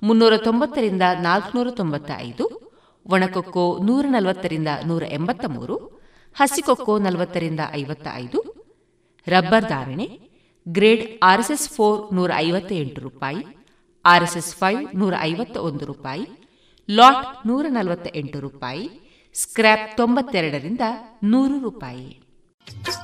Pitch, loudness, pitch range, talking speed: 195 Hz, -20 LUFS, 170-240 Hz, 100 wpm